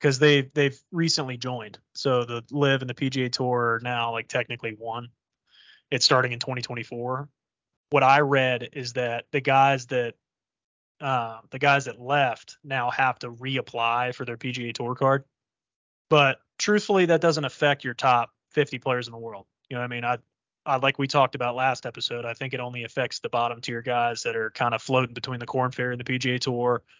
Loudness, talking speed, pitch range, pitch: -25 LUFS, 200 wpm, 120-135 Hz, 125 Hz